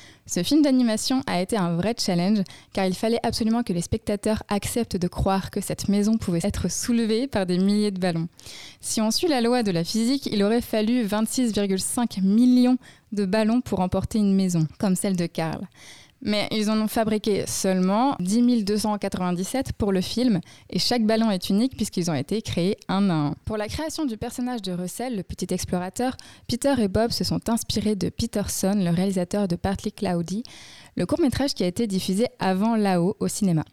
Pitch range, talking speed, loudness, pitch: 185-230 Hz, 195 wpm, -24 LUFS, 205 Hz